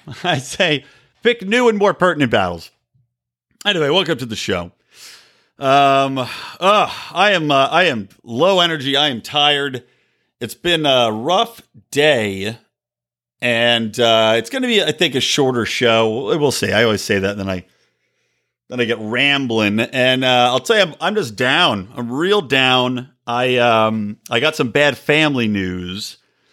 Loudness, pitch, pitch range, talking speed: -16 LUFS, 125 Hz, 115-145 Hz, 165 wpm